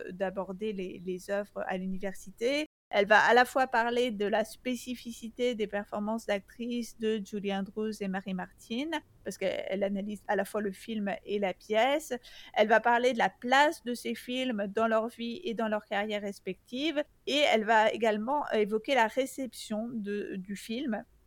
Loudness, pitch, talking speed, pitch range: -31 LUFS, 220 Hz, 170 wpm, 200-245 Hz